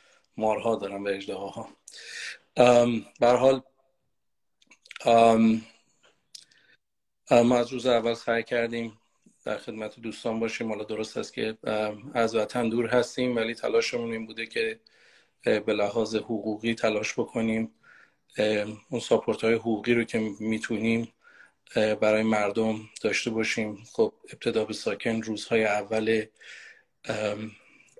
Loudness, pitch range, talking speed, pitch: -27 LUFS, 110-115 Hz, 115 wpm, 115 Hz